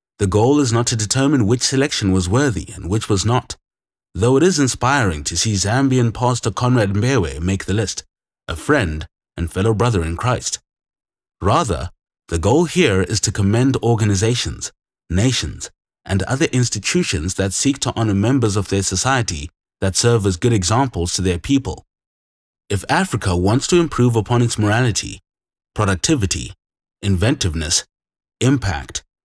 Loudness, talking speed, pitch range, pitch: -18 LUFS, 150 wpm, 95-125 Hz, 105 Hz